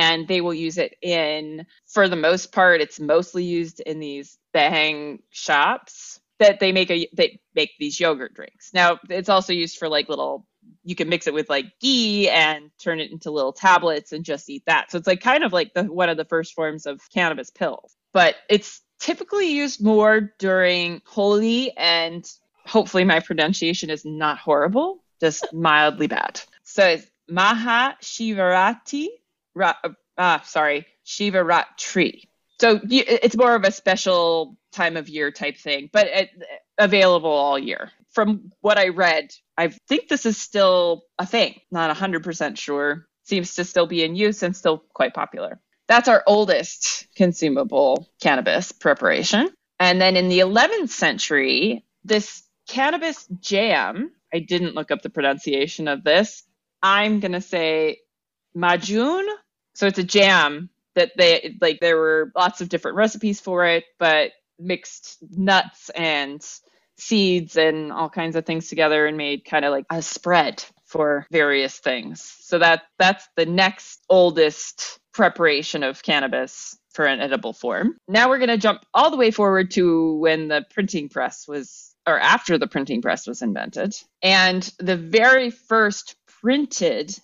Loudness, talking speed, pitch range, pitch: -20 LUFS, 165 wpm, 160-210 Hz, 180 Hz